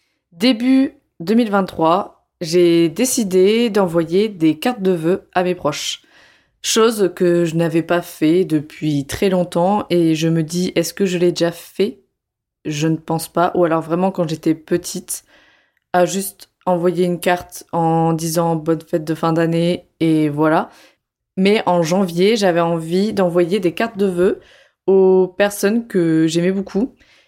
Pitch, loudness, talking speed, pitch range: 180 Hz, -17 LUFS, 155 wpm, 165-195 Hz